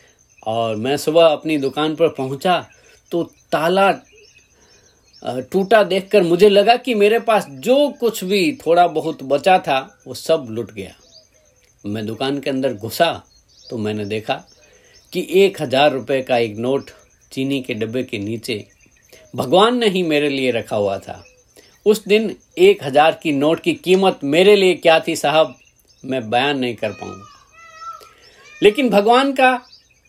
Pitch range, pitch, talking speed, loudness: 130-205 Hz, 160 Hz, 150 wpm, -17 LUFS